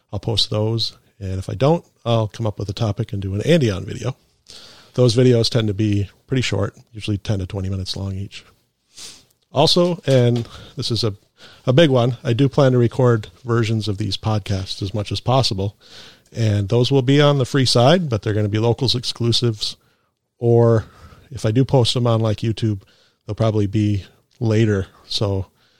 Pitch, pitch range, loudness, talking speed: 115 Hz, 105-125 Hz, -19 LUFS, 190 wpm